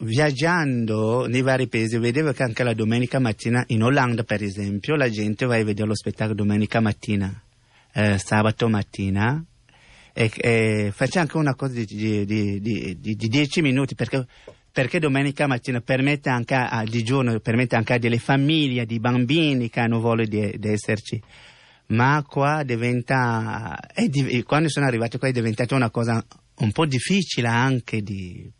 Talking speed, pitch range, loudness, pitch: 165 wpm, 110-135 Hz, -22 LUFS, 120 Hz